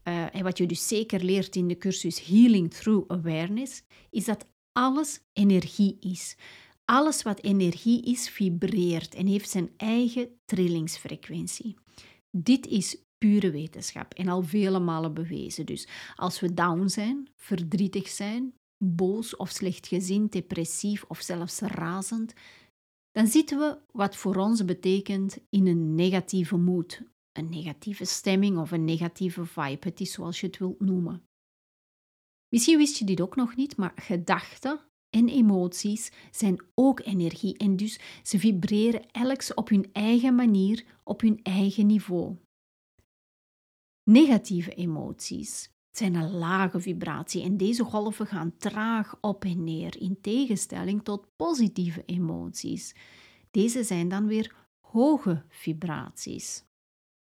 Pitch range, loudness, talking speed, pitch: 180-220 Hz, -27 LUFS, 135 wpm, 195 Hz